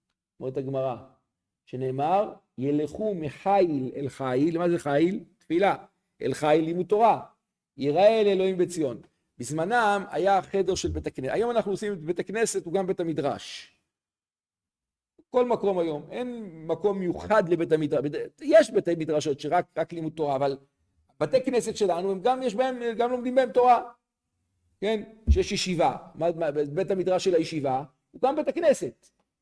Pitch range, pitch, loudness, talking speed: 145-220 Hz, 180 Hz, -26 LUFS, 145 wpm